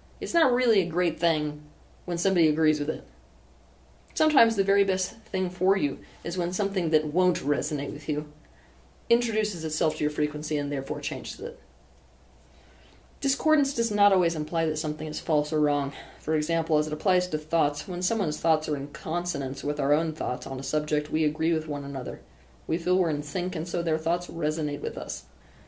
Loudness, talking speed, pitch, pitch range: -27 LUFS, 195 wpm, 155 Hz, 145-180 Hz